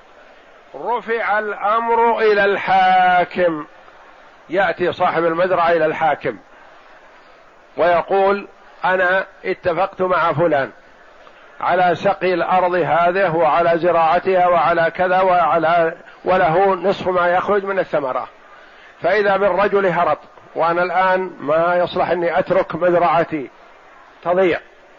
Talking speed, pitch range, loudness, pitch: 95 wpm, 175-190 Hz, -17 LUFS, 180 Hz